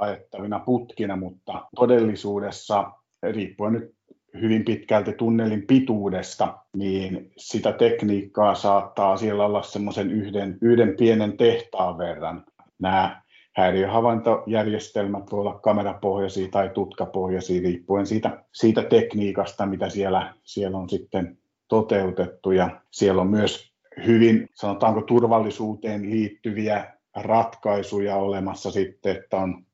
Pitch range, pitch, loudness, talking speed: 95-110 Hz, 100 Hz, -23 LUFS, 105 wpm